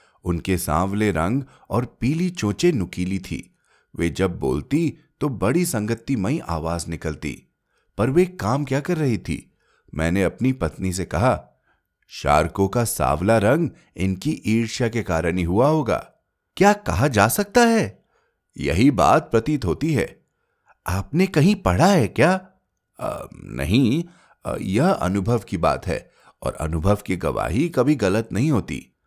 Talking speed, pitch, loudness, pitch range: 140 wpm, 105 Hz, -21 LUFS, 85-145 Hz